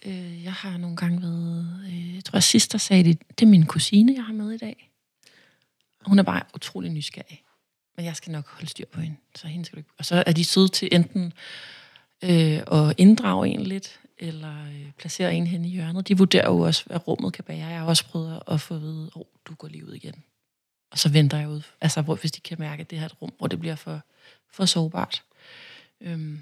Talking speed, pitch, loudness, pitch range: 225 wpm, 170 Hz, -22 LUFS, 155-190 Hz